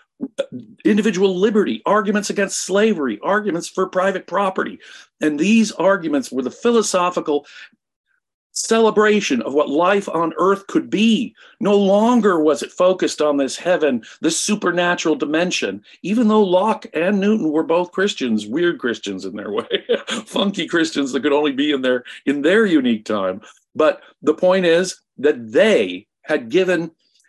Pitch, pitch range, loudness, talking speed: 185 Hz, 155-215 Hz, -18 LUFS, 145 wpm